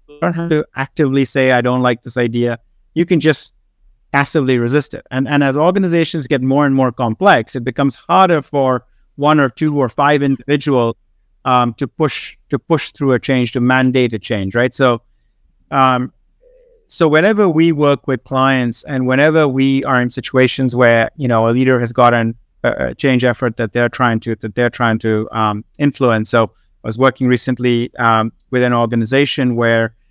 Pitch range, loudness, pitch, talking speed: 120-140 Hz, -15 LUFS, 130 Hz, 185 wpm